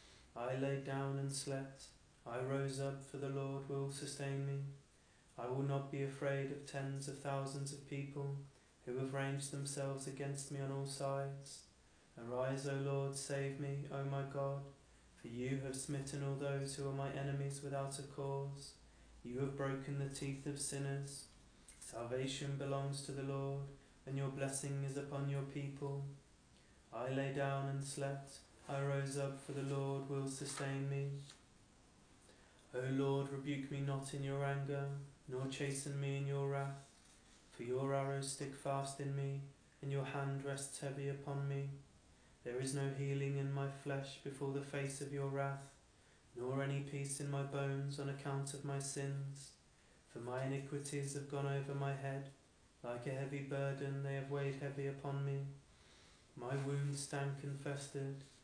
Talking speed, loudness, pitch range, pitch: 165 wpm, -43 LUFS, 135-140 Hz, 140 Hz